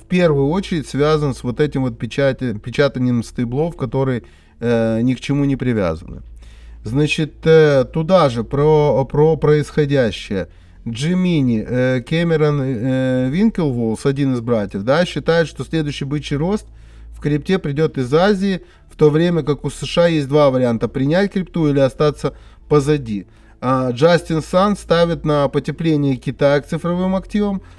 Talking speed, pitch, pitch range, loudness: 145 wpm, 145 Hz, 125-160 Hz, -17 LUFS